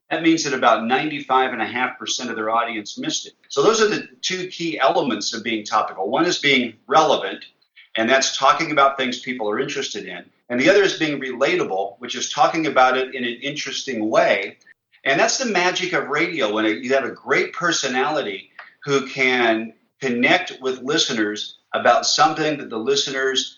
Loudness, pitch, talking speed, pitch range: -20 LUFS, 130 Hz, 180 wpm, 115-155 Hz